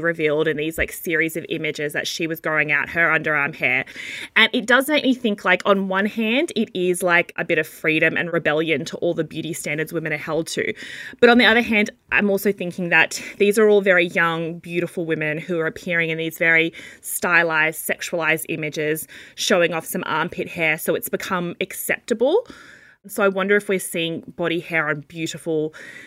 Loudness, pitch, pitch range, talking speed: -20 LUFS, 170 Hz, 160-195 Hz, 200 wpm